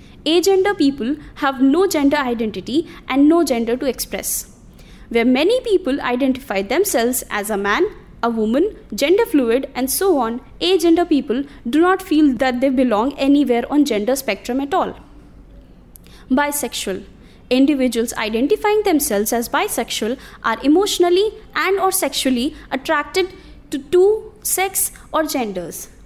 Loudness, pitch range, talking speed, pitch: -18 LUFS, 245-350 Hz, 130 wpm, 280 Hz